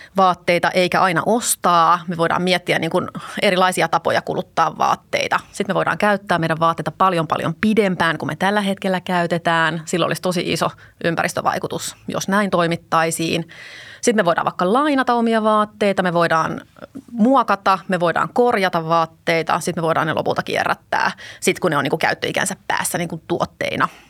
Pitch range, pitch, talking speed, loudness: 165-200 Hz, 180 Hz, 165 wpm, -19 LUFS